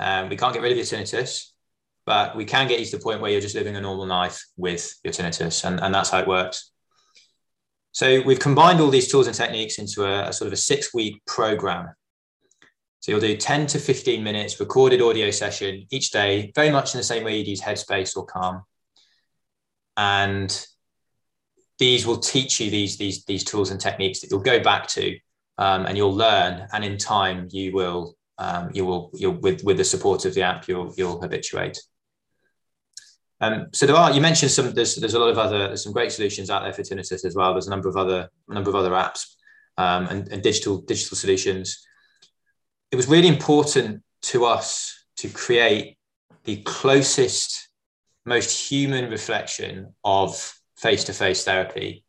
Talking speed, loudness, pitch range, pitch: 190 wpm, -22 LUFS, 95-145 Hz, 105 Hz